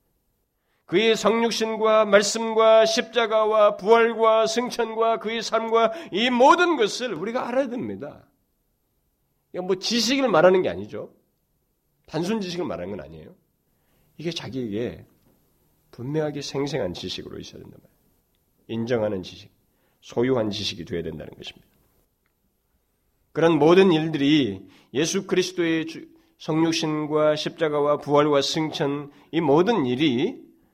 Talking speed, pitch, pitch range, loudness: 280 characters per minute, 180 Hz, 145-225 Hz, -22 LUFS